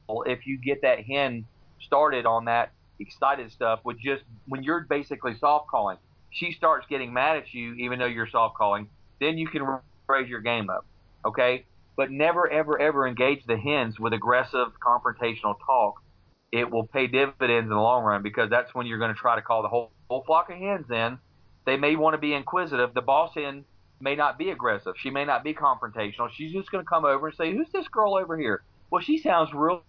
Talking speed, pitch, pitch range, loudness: 215 wpm, 130 Hz, 115-155 Hz, -26 LUFS